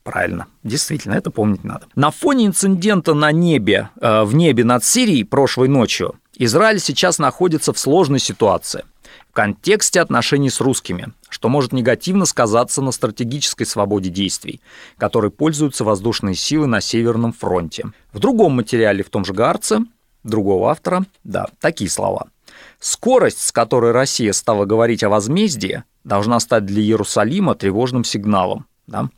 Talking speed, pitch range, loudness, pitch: 145 wpm, 110-155 Hz, -16 LUFS, 125 Hz